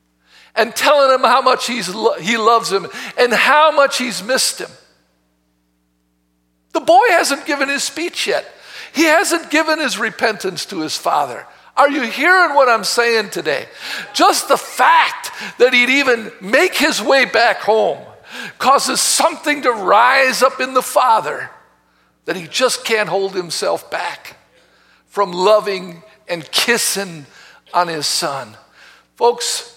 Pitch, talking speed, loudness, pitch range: 235 Hz, 145 wpm, -15 LUFS, 190-275 Hz